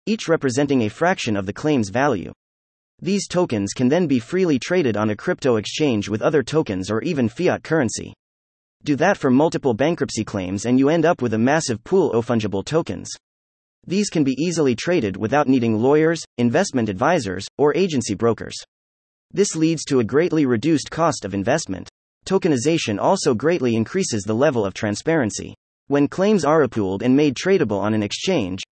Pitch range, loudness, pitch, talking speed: 100-160 Hz, -20 LUFS, 125 Hz, 175 wpm